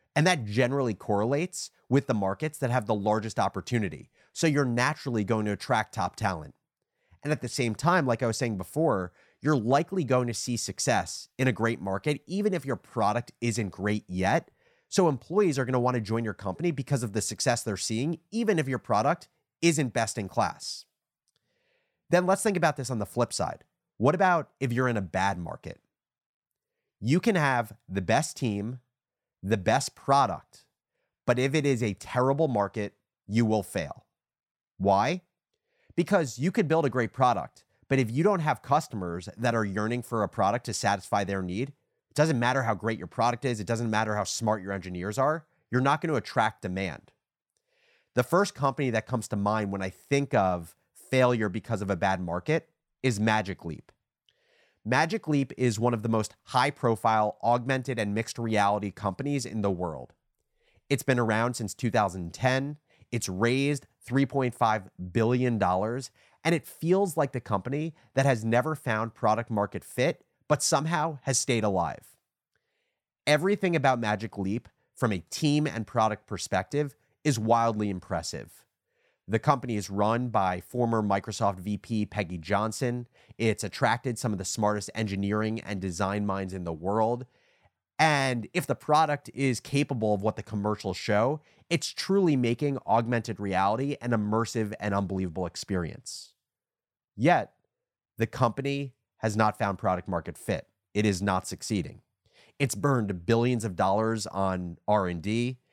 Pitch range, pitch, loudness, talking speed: 105-135 Hz, 115 Hz, -28 LUFS, 165 wpm